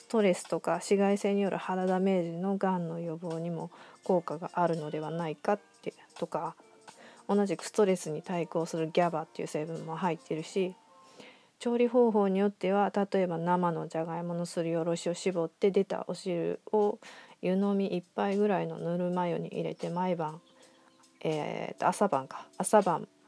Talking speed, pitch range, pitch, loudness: 335 characters per minute, 165-200 Hz, 180 Hz, -31 LUFS